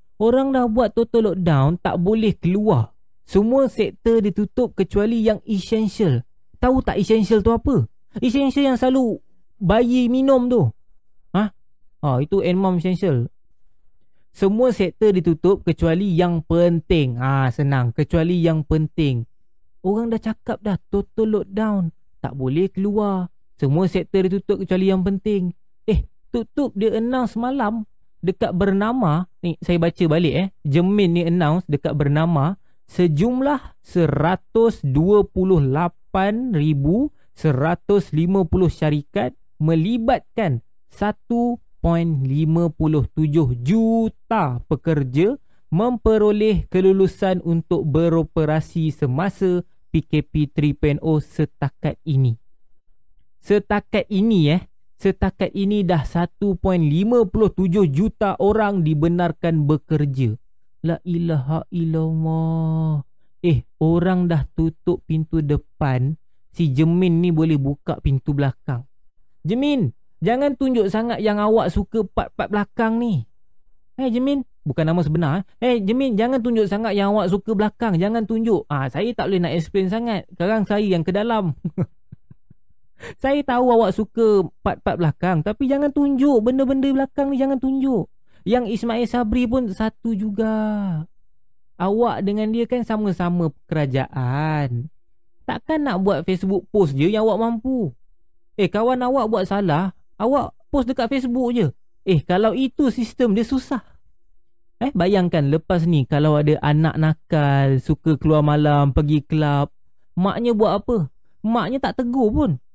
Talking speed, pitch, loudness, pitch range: 120 wpm, 185 Hz, -20 LUFS, 155-220 Hz